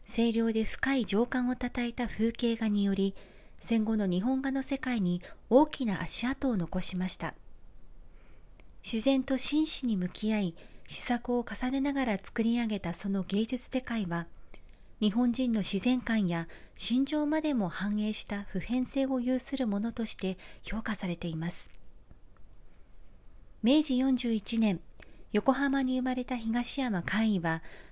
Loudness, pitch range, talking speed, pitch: -30 LUFS, 190-255 Hz, 260 characters per minute, 225 Hz